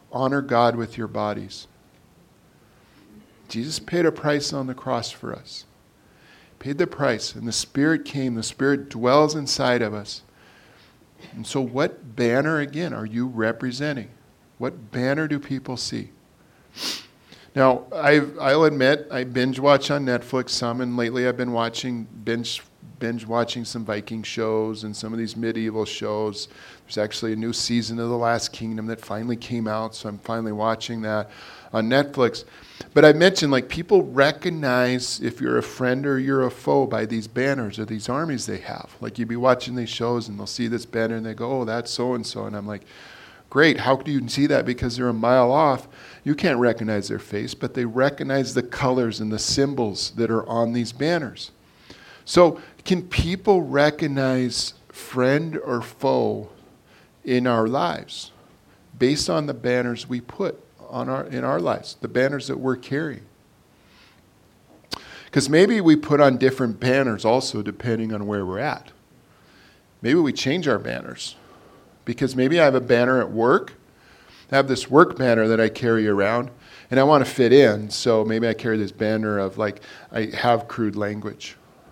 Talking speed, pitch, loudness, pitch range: 175 wpm, 120 Hz, -22 LUFS, 110-135 Hz